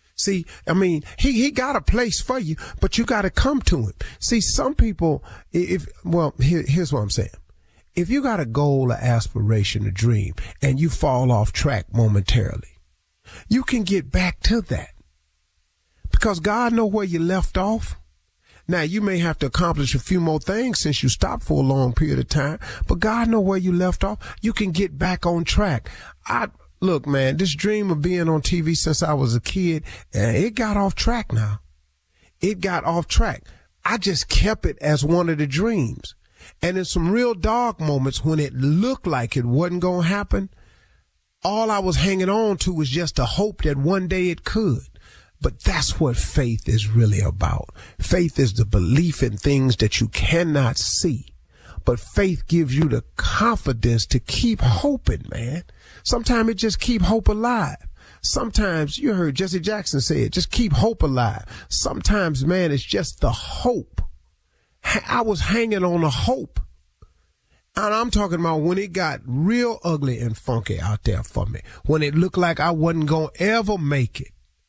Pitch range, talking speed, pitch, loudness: 115-190 Hz, 185 wpm, 155 Hz, -21 LUFS